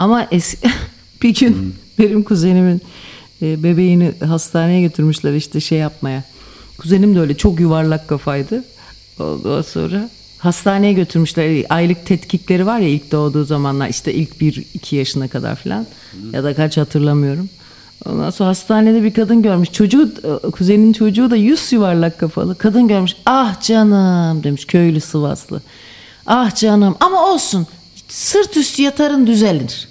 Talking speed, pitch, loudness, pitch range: 140 wpm, 180 Hz, -14 LUFS, 155-215 Hz